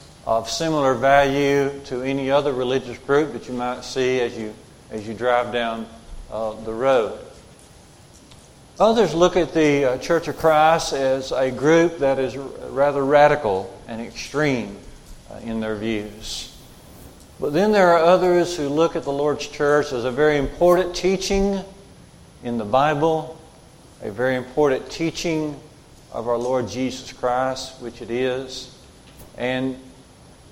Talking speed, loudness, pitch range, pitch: 145 wpm, -21 LUFS, 125-155 Hz, 135 Hz